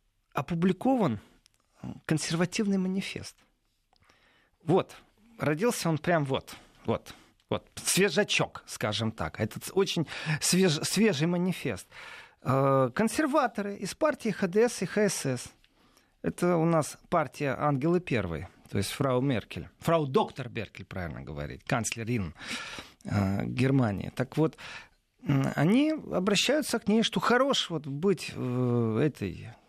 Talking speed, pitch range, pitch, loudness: 105 wpm, 120-195 Hz, 155 Hz, -29 LUFS